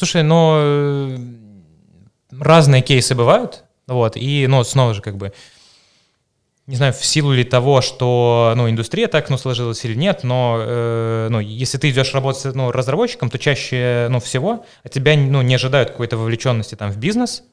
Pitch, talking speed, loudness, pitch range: 130 Hz, 170 wpm, -16 LUFS, 120-140 Hz